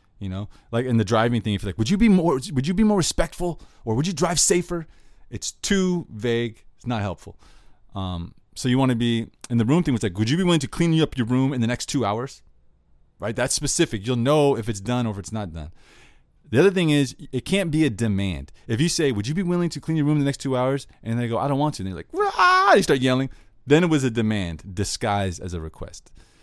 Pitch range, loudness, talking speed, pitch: 105-150 Hz, -22 LUFS, 265 wpm, 125 Hz